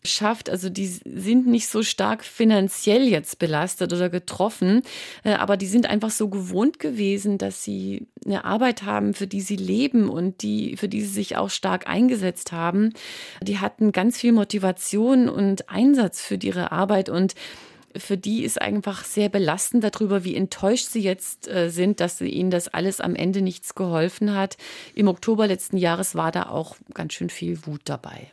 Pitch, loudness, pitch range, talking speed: 200 Hz, -23 LUFS, 180-220 Hz, 175 wpm